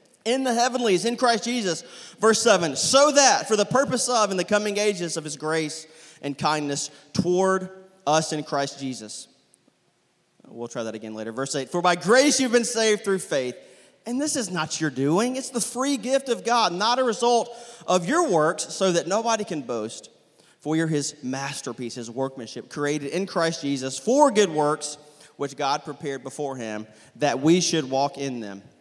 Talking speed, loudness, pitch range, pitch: 185 wpm, -23 LUFS, 140-230 Hz, 165 Hz